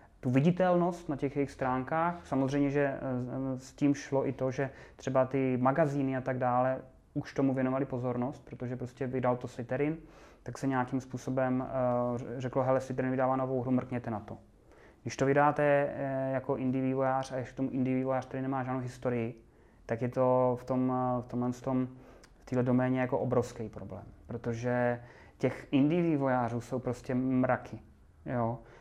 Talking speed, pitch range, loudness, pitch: 165 wpm, 125-135 Hz, -32 LUFS, 130 Hz